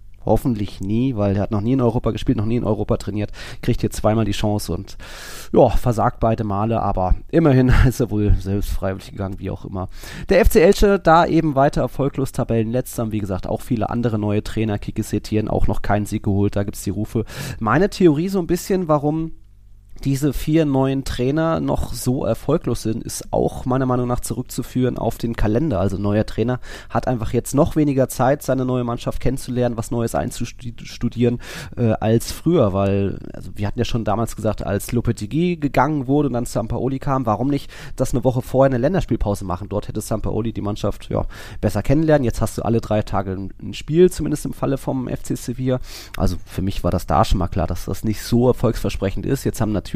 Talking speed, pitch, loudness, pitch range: 205 wpm, 115 Hz, -20 LUFS, 105-130 Hz